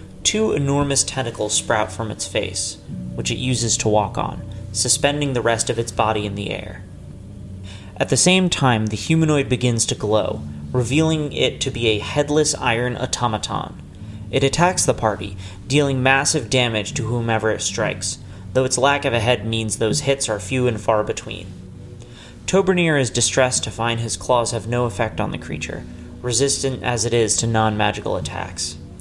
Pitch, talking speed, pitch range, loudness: 115 Hz, 175 wpm, 105-130 Hz, -20 LUFS